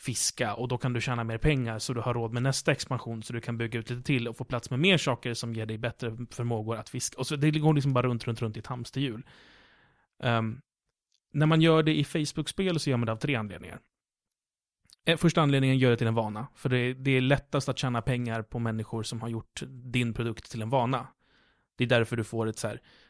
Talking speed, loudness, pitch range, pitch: 250 wpm, -29 LUFS, 115-135 Hz, 125 Hz